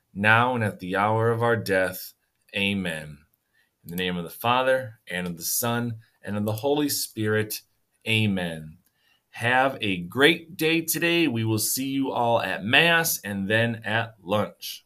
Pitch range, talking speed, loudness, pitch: 95-125 Hz, 165 wpm, -24 LUFS, 110 Hz